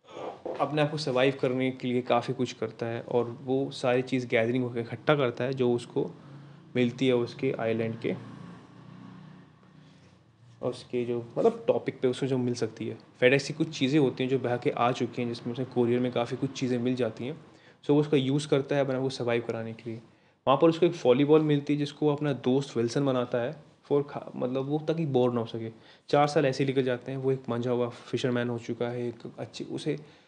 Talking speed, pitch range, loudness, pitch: 220 wpm, 120-140 Hz, -28 LUFS, 125 Hz